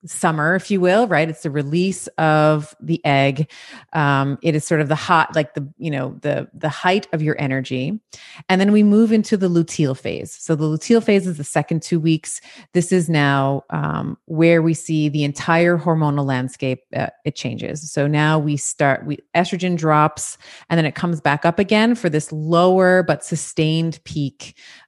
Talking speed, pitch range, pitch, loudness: 190 wpm, 150-175 Hz, 155 Hz, -19 LUFS